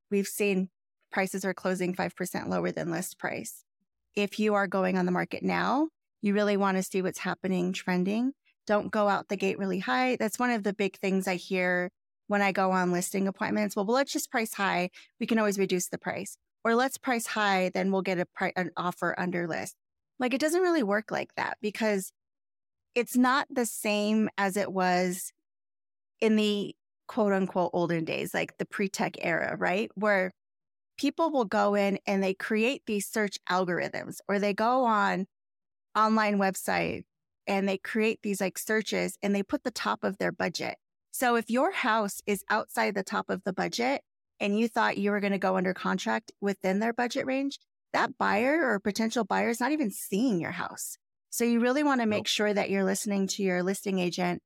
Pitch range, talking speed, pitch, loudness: 190-225 Hz, 195 wpm, 200 Hz, -29 LUFS